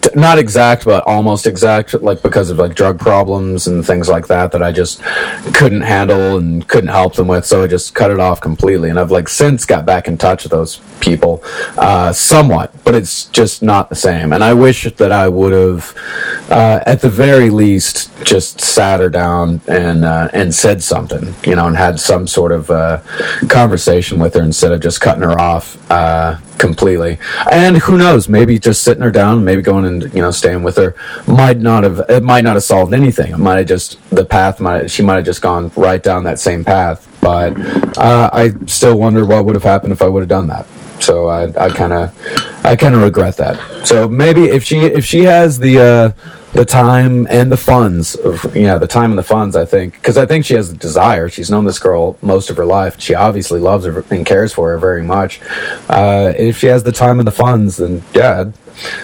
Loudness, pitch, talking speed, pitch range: -10 LUFS, 100 Hz, 225 wpm, 90-120 Hz